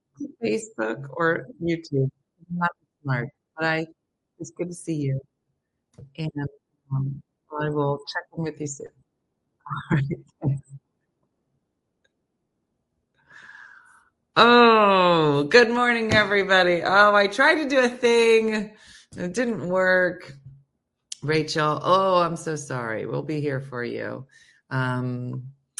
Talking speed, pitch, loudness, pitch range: 110 wpm, 165 Hz, -22 LUFS, 140-205 Hz